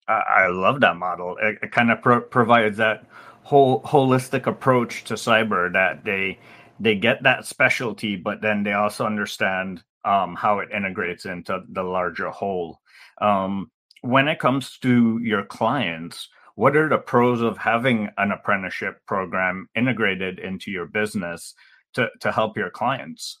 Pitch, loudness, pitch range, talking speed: 110 Hz, -21 LUFS, 100-125 Hz, 150 wpm